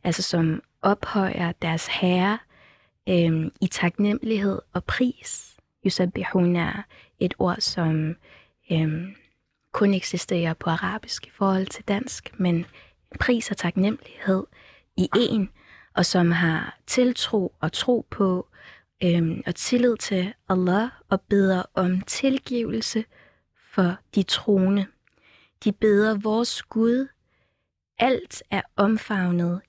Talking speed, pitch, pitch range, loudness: 115 wpm, 190 Hz, 175-215 Hz, -24 LUFS